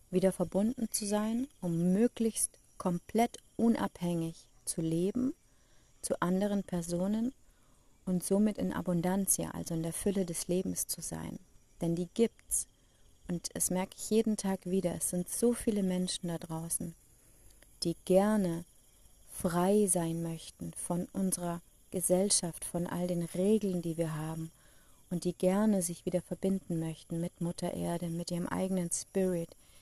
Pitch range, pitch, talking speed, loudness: 170-195 Hz, 180 Hz, 145 wpm, -33 LUFS